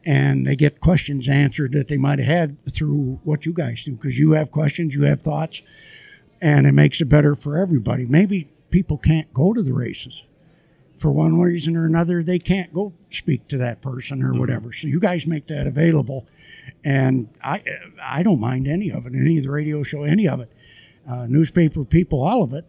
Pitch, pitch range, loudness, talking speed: 150 Hz, 135-165 Hz, -20 LUFS, 205 wpm